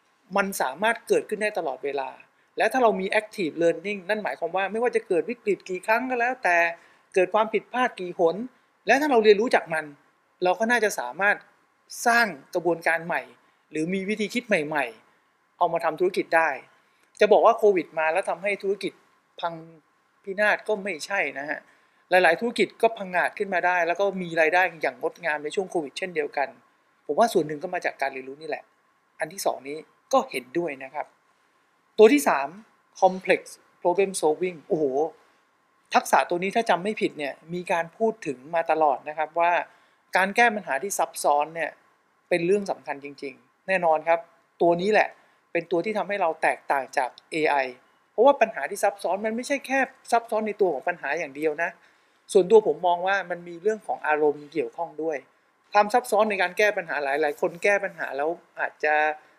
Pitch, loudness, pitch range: 195 Hz, -24 LUFS, 165-225 Hz